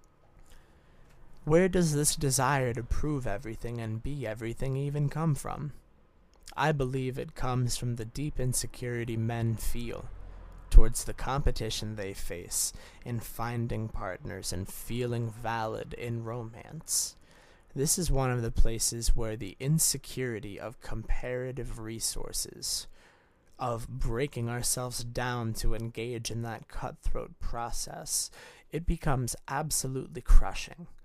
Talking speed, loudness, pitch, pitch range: 120 wpm, -32 LUFS, 120 Hz, 110-130 Hz